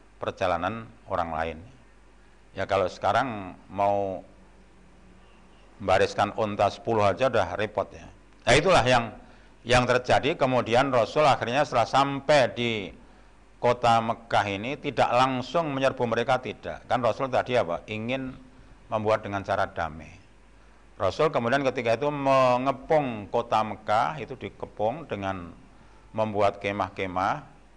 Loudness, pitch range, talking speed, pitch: -25 LUFS, 100-130 Hz, 115 wpm, 110 Hz